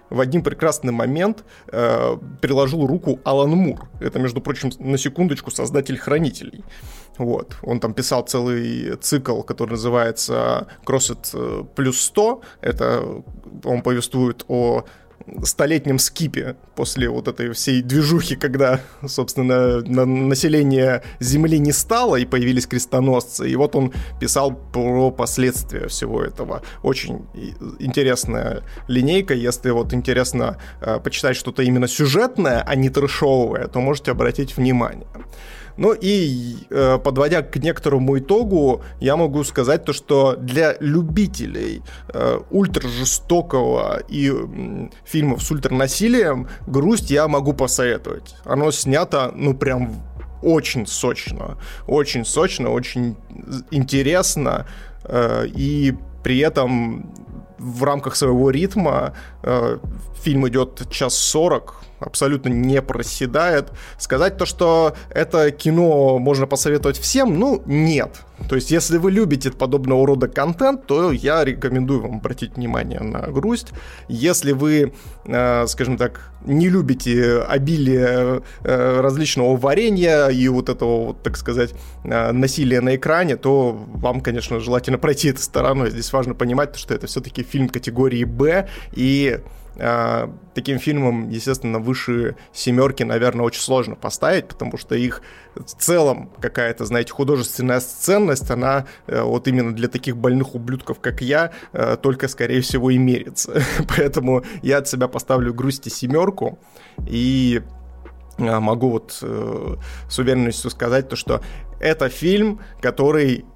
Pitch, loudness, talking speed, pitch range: 130 Hz, -19 LUFS, 120 wpm, 125-145 Hz